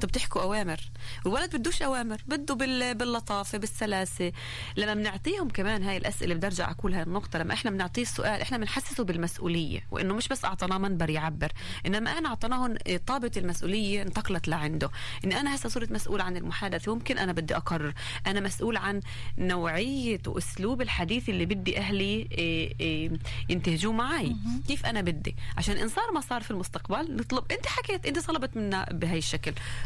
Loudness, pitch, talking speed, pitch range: -31 LUFS, 190 Hz, 160 wpm, 160-235 Hz